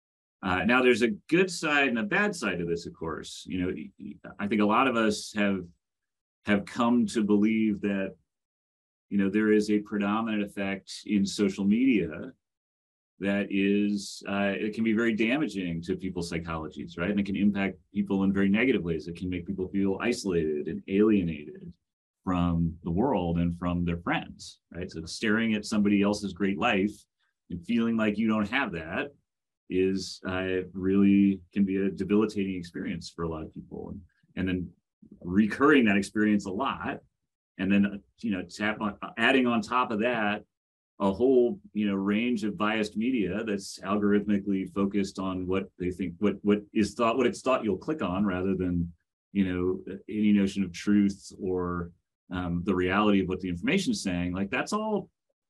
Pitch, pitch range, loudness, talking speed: 100 Hz, 90-105 Hz, -28 LUFS, 180 wpm